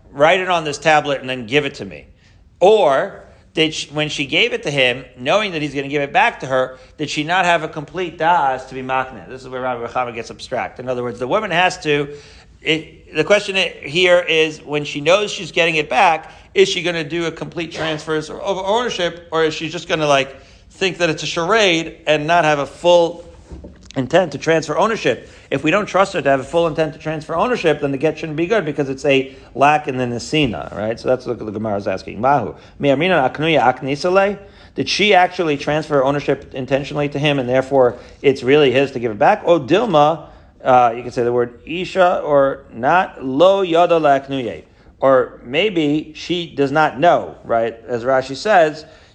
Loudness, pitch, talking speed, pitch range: -17 LUFS, 150 Hz, 210 wpm, 130-170 Hz